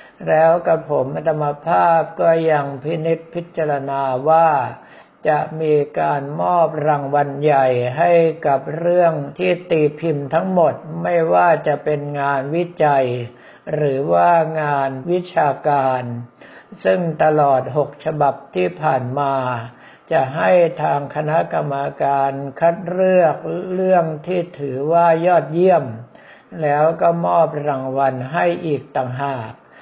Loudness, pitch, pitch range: -18 LUFS, 150 Hz, 140-165 Hz